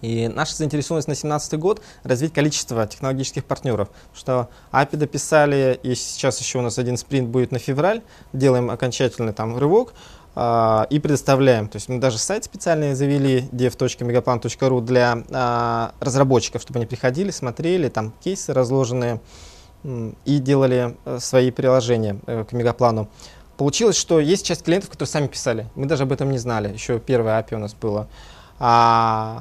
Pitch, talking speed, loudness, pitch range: 125 Hz, 155 wpm, -20 LUFS, 120-140 Hz